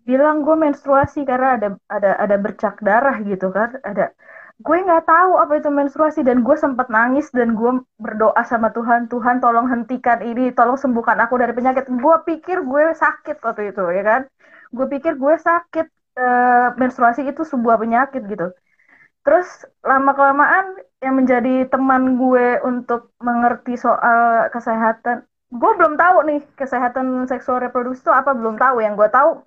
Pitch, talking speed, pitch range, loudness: 255 Hz, 160 wpm, 235-290 Hz, -17 LUFS